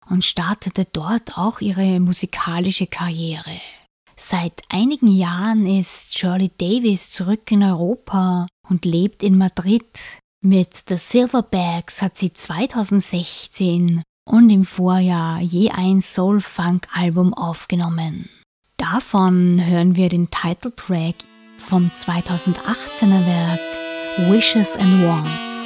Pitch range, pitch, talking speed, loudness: 175-200 Hz, 185 Hz, 105 wpm, -18 LUFS